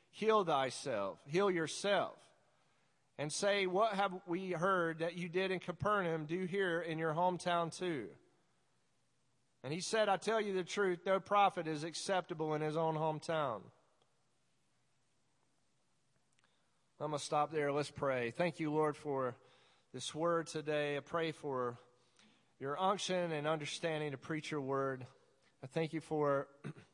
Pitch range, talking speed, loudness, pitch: 145-180 Hz, 145 wpm, -37 LUFS, 160 Hz